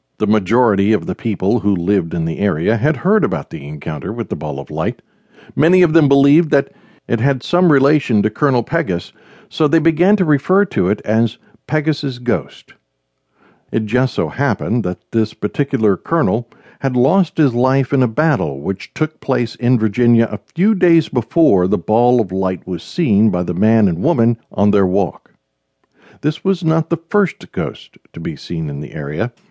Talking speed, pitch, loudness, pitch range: 185 wpm, 125 Hz, -16 LUFS, 105-155 Hz